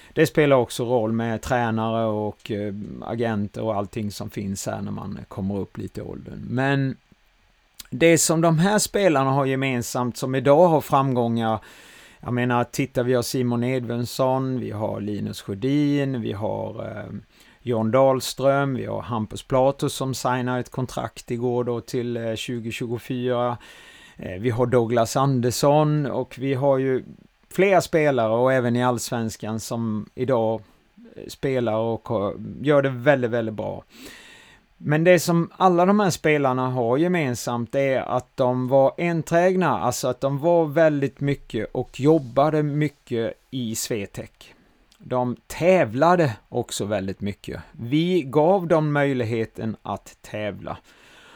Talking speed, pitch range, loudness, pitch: 140 wpm, 115-140 Hz, -22 LUFS, 125 Hz